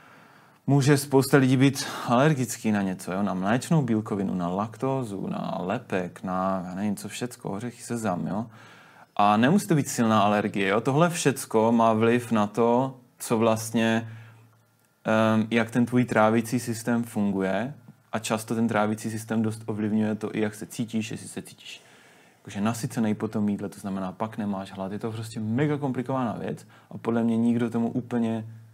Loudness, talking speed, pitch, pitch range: -26 LUFS, 170 wpm, 115 Hz, 105-120 Hz